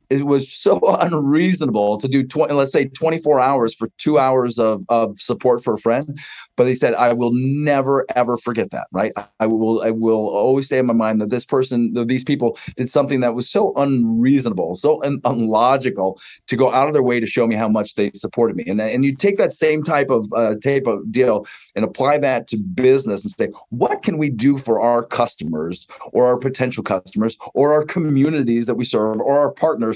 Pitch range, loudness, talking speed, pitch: 115-140 Hz, -18 LUFS, 215 wpm, 125 Hz